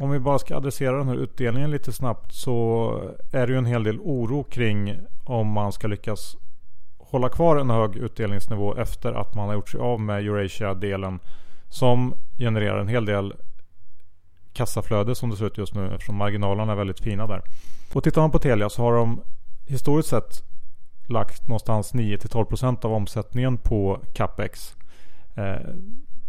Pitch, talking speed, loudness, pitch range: 110 Hz, 165 wpm, -25 LUFS, 100-125 Hz